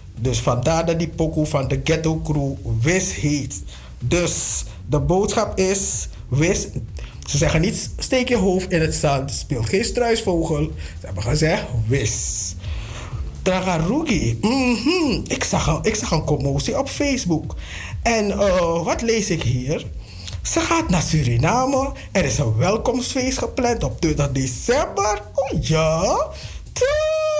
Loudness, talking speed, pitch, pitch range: -20 LUFS, 140 wpm, 160 Hz, 125-210 Hz